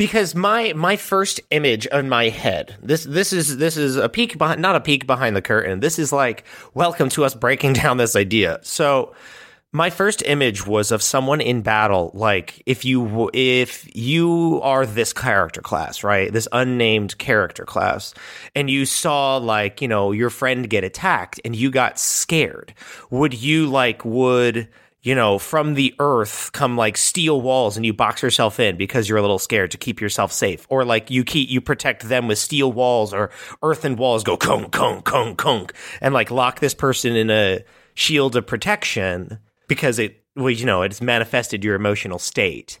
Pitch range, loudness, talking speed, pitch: 110-145 Hz, -19 LUFS, 190 wpm, 130 Hz